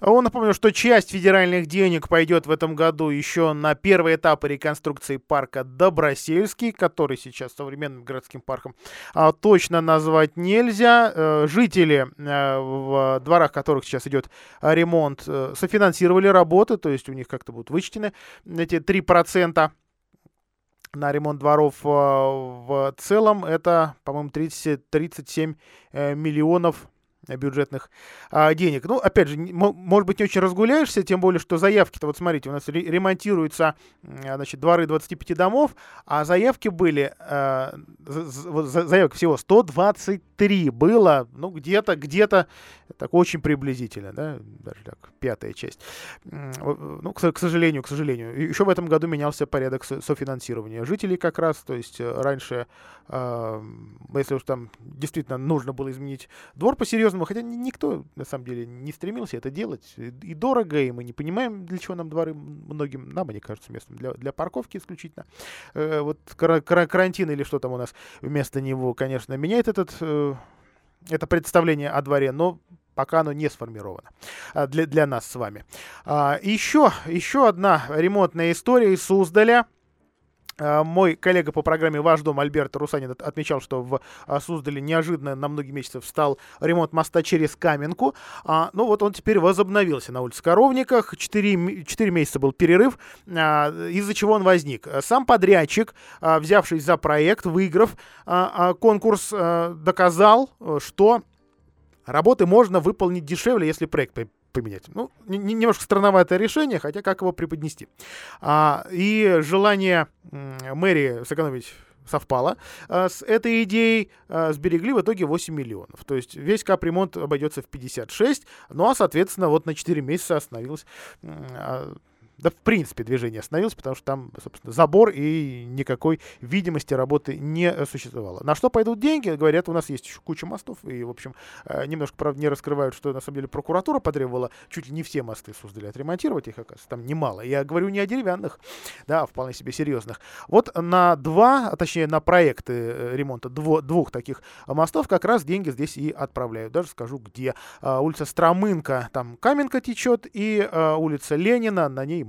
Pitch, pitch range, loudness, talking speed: 160 Hz, 140-185 Hz, -22 LUFS, 150 wpm